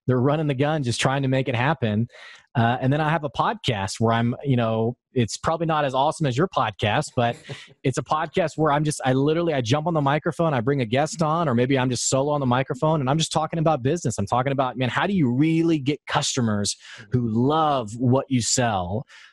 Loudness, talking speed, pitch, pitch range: -23 LUFS, 240 wpm, 140 Hz, 125-155 Hz